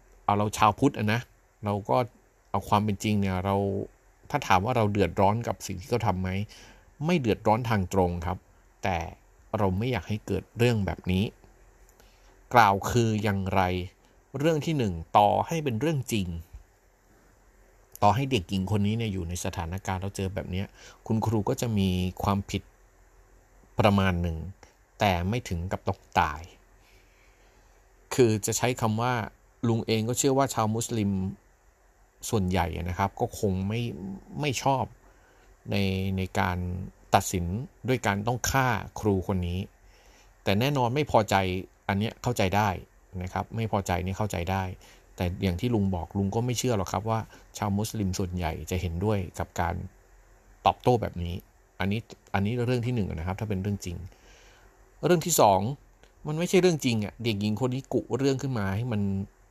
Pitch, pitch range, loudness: 100 Hz, 95-115 Hz, -28 LUFS